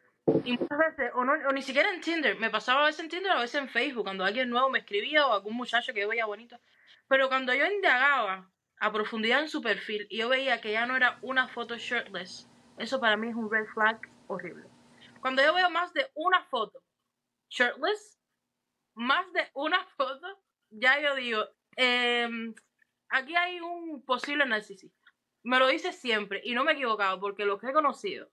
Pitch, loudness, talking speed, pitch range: 255 Hz, -28 LUFS, 200 wpm, 225-300 Hz